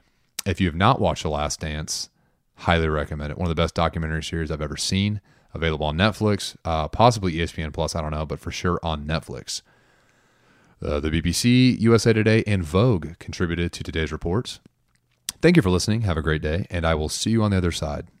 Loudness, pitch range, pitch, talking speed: -23 LUFS, 80-100 Hz, 85 Hz, 205 wpm